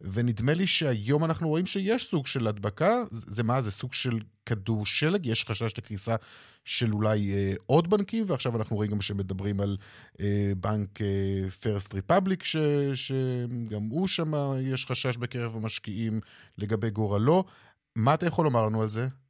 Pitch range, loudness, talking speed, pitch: 105-145 Hz, -28 LUFS, 160 wpm, 115 Hz